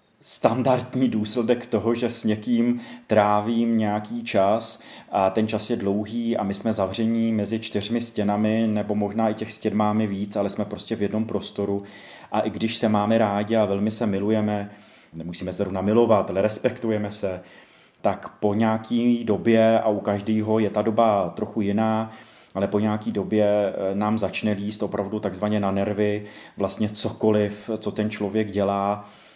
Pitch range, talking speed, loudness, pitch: 105-110 Hz, 165 wpm, -23 LUFS, 105 Hz